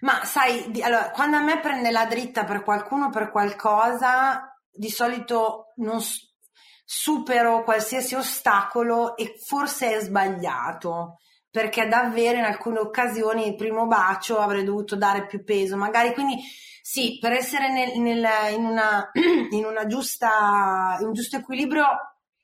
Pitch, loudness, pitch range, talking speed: 230 Hz, -23 LUFS, 215-255 Hz, 145 wpm